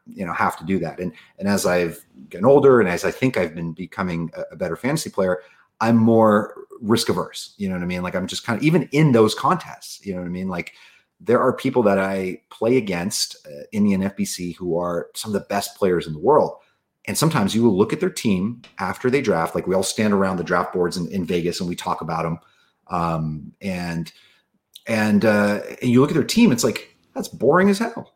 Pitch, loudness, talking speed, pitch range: 95 Hz, -21 LUFS, 240 wpm, 90-120 Hz